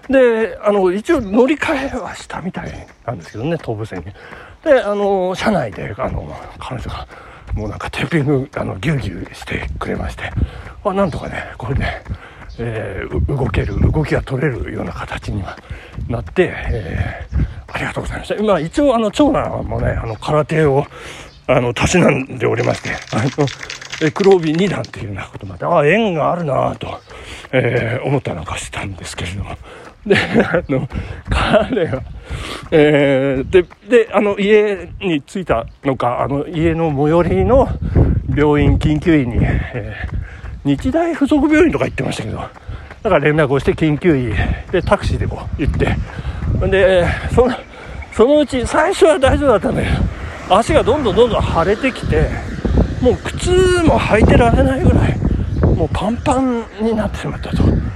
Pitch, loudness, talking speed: 150 Hz, -16 LUFS, 310 characters per minute